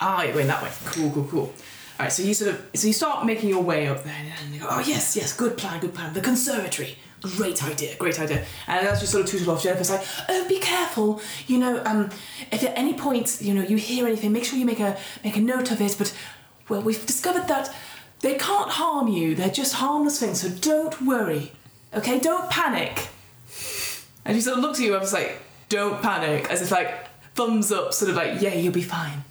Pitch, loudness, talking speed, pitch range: 210 Hz, -24 LUFS, 240 wpm, 180-250 Hz